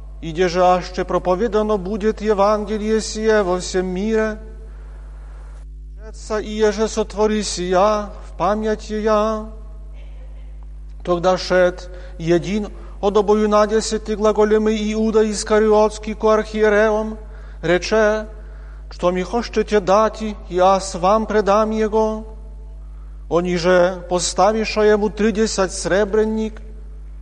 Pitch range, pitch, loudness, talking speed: 180-215 Hz, 210 Hz, -18 LUFS, 100 wpm